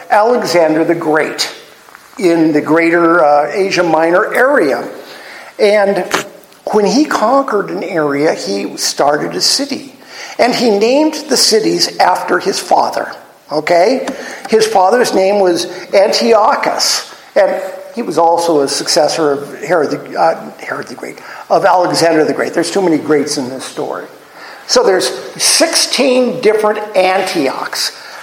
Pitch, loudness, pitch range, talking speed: 190 Hz, -12 LUFS, 165-220 Hz, 135 wpm